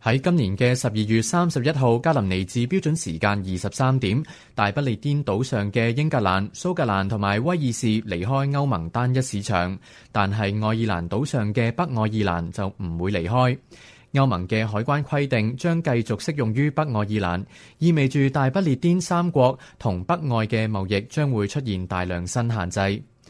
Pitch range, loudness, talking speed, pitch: 100-140 Hz, -23 LUFS, 275 characters per minute, 115 Hz